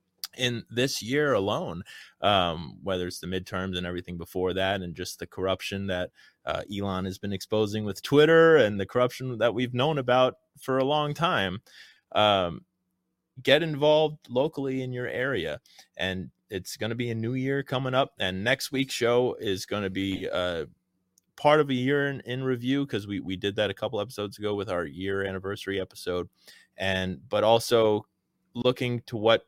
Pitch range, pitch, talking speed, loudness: 95-130 Hz, 115 Hz, 180 wpm, -27 LUFS